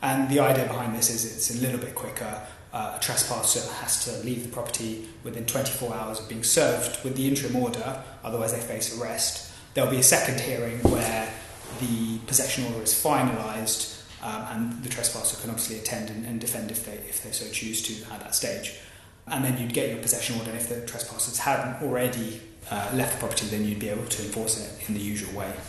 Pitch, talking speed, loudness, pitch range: 115 Hz, 215 wpm, -26 LUFS, 110-125 Hz